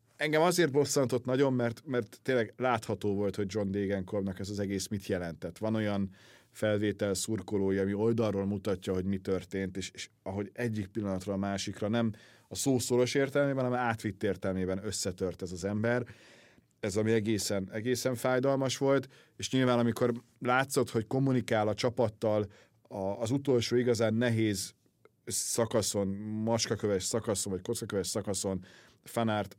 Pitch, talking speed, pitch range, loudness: 110 Hz, 140 wpm, 100-125 Hz, -31 LUFS